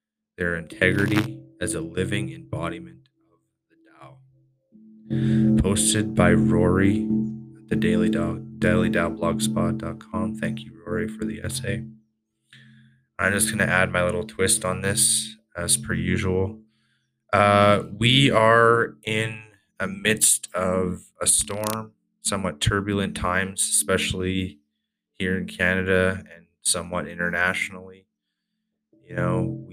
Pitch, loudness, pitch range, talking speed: 105 Hz, -22 LUFS, 90-110 Hz, 115 wpm